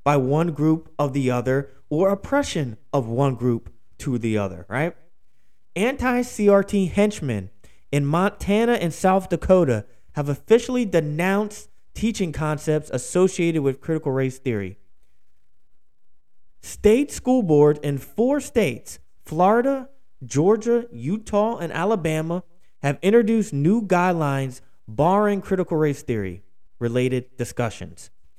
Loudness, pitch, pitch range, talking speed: -22 LUFS, 155 Hz, 125-200 Hz, 115 wpm